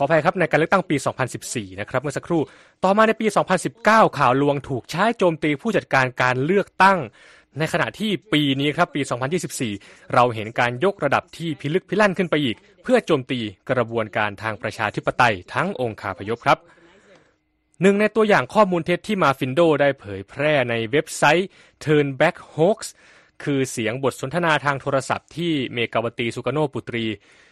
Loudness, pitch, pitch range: -21 LUFS, 145 Hz, 125-175 Hz